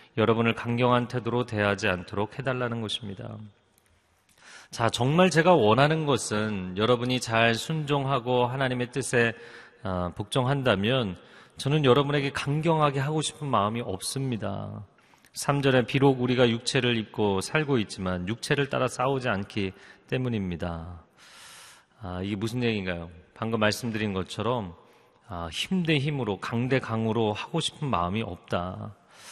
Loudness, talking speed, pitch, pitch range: -26 LUFS, 300 characters per minute, 115 Hz, 100-130 Hz